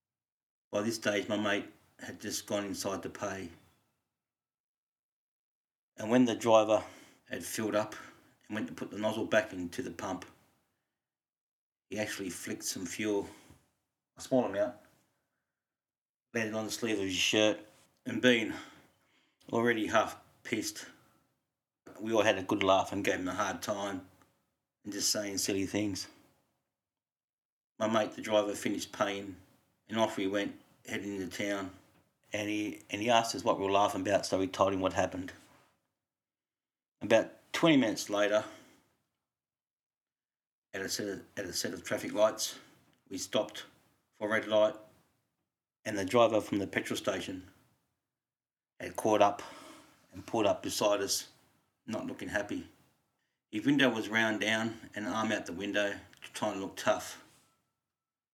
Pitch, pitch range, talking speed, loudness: 105 Hz, 100-110 Hz, 155 wpm, -32 LUFS